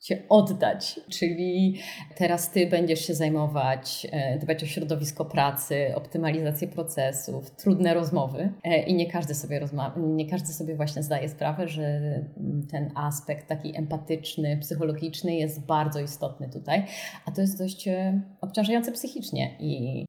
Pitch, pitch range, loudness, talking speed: 160 Hz, 150-175 Hz, -28 LUFS, 130 wpm